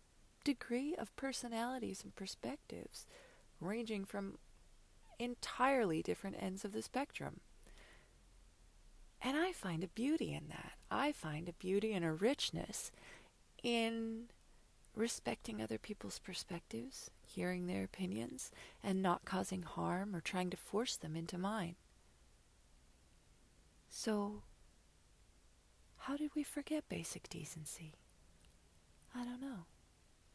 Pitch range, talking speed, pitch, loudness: 160-245 Hz, 110 wpm, 195 Hz, -42 LUFS